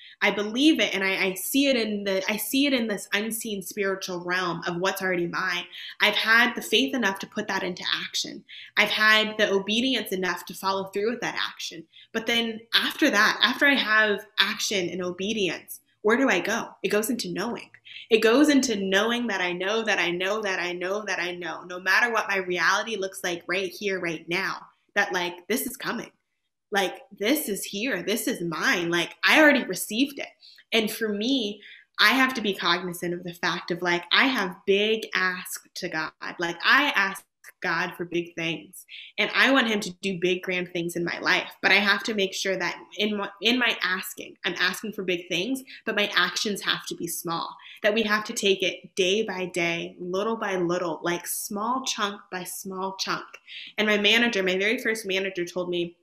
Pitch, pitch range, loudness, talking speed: 195 Hz, 180-220 Hz, -24 LUFS, 210 wpm